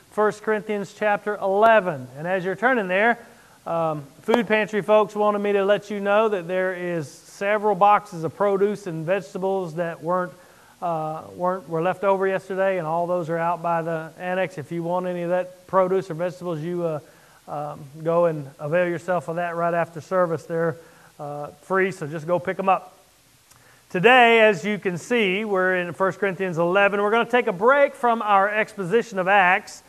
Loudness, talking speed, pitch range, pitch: -22 LUFS, 190 wpm, 170-205 Hz, 185 Hz